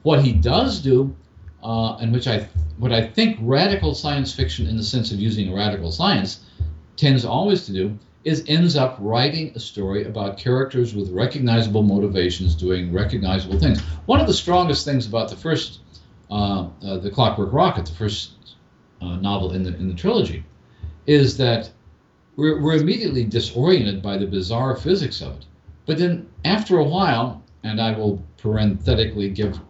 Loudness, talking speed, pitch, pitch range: -21 LUFS, 170 wpm, 110 Hz, 95-130 Hz